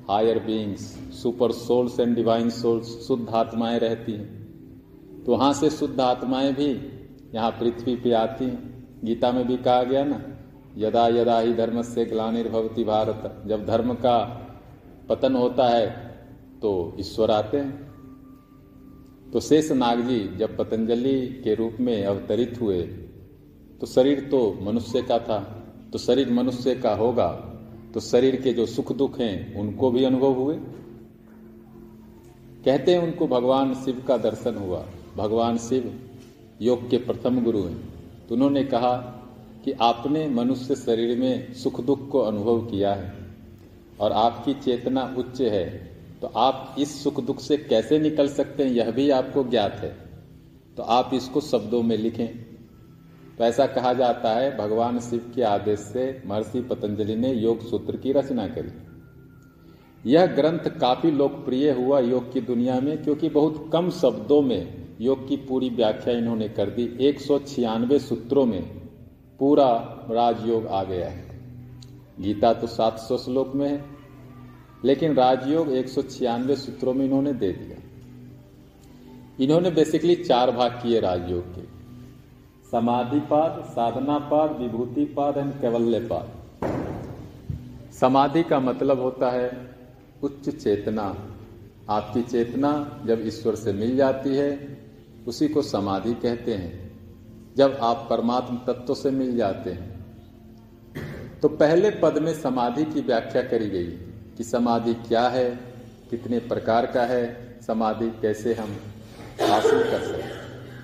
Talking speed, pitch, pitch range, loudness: 140 wpm, 125 Hz, 115-135 Hz, -24 LUFS